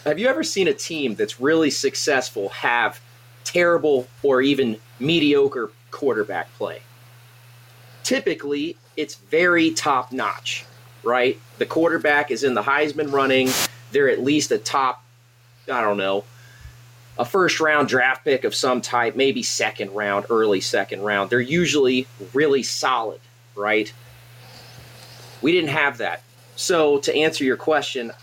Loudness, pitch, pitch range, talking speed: -21 LUFS, 130 Hz, 120-150 Hz, 140 wpm